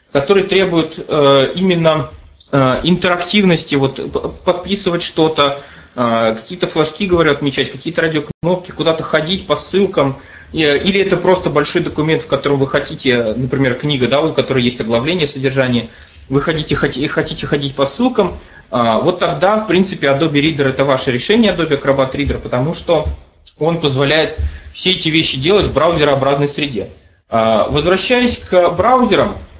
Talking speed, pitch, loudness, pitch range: 135 wpm, 150 Hz, -14 LUFS, 135-175 Hz